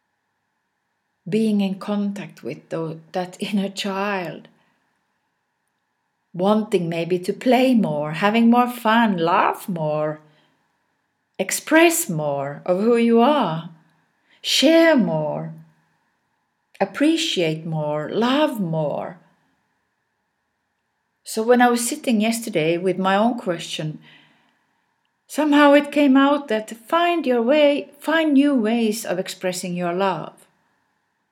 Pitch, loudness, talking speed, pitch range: 205 Hz, -20 LUFS, 105 wpm, 170-245 Hz